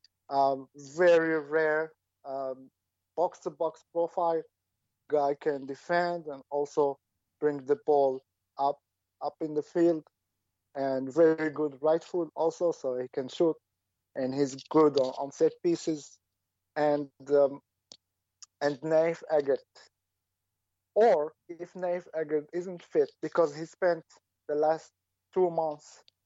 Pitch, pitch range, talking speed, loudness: 145 Hz, 130-165 Hz, 125 wpm, -29 LUFS